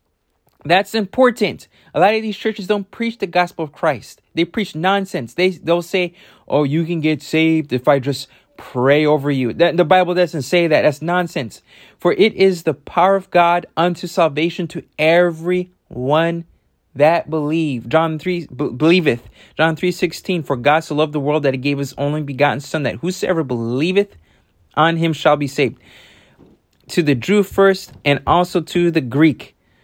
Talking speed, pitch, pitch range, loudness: 175 wpm, 165 Hz, 145-180 Hz, -17 LUFS